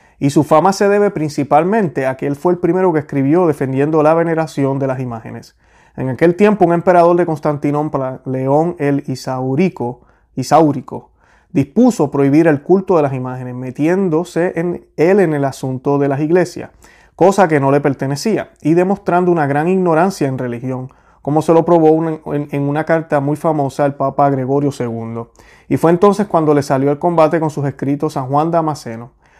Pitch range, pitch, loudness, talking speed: 140-170 Hz, 150 Hz, -15 LUFS, 180 wpm